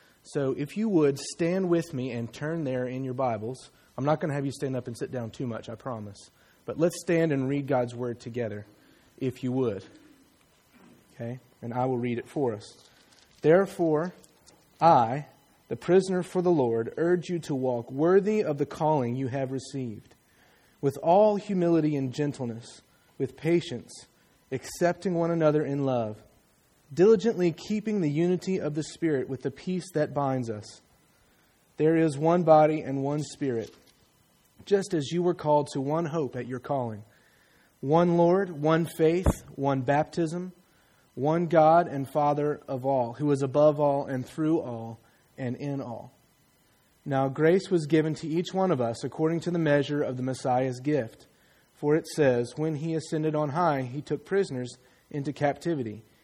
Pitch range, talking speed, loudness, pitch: 130-165 Hz, 170 wpm, -27 LUFS, 145 Hz